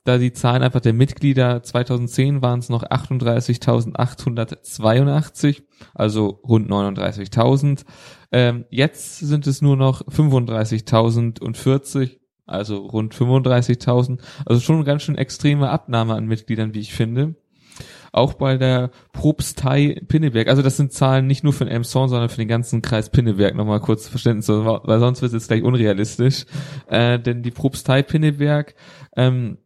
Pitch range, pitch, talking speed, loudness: 115-140 Hz, 125 Hz, 145 wpm, -19 LUFS